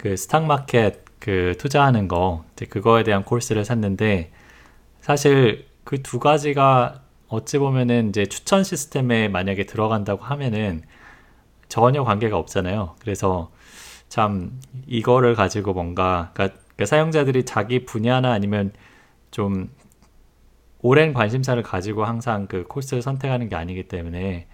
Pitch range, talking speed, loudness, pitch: 95-130 Hz, 295 characters per minute, -21 LUFS, 110 Hz